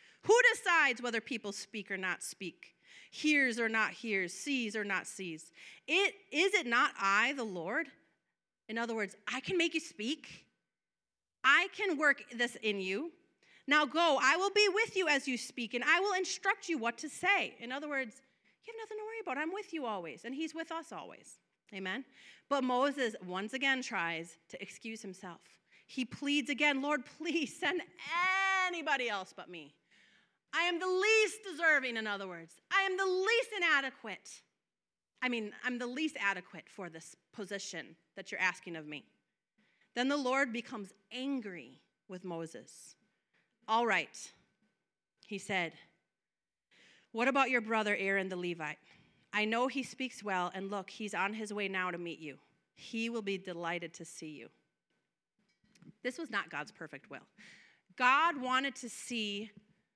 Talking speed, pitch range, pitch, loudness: 170 wpm, 195-305 Hz, 240 Hz, -33 LUFS